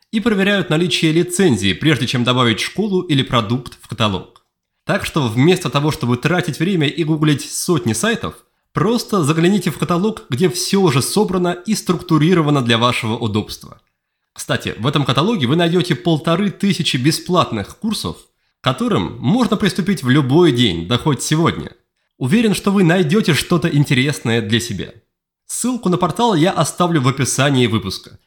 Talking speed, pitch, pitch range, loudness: 155 wpm, 160 Hz, 125-180 Hz, -16 LUFS